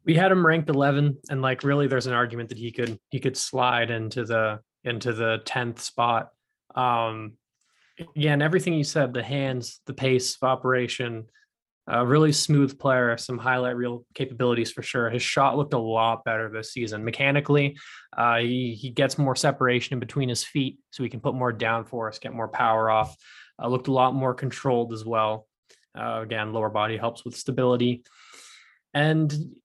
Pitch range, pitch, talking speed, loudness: 115-135 Hz, 125 Hz, 185 wpm, -25 LUFS